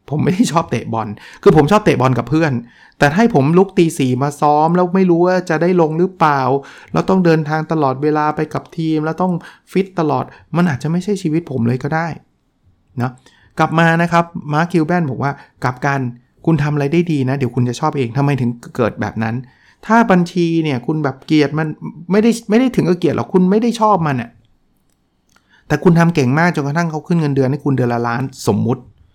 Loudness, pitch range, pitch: -16 LUFS, 135-175 Hz, 155 Hz